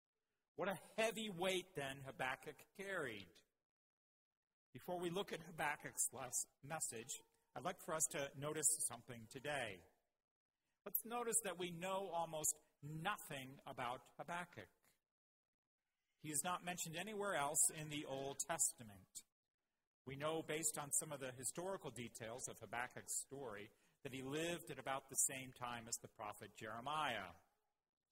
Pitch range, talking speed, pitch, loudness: 130-175 Hz, 140 wpm, 150 Hz, -44 LUFS